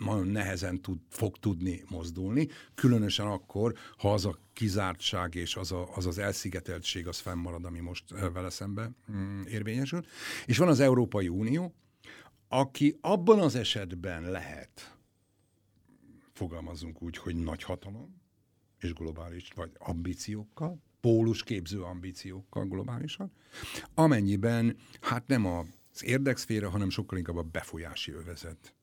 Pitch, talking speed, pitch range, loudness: 100 Hz, 125 wpm, 90-115 Hz, -32 LUFS